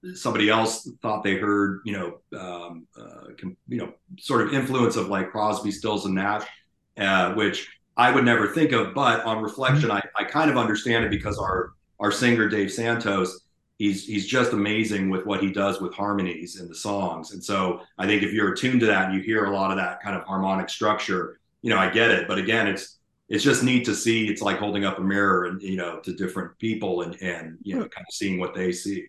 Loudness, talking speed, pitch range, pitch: -24 LUFS, 225 wpm, 95-110 Hz, 100 Hz